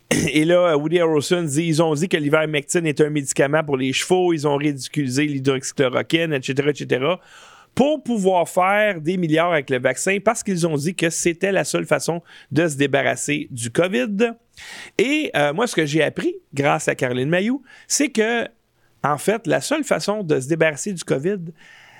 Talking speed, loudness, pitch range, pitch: 185 wpm, -20 LUFS, 145-200 Hz, 165 Hz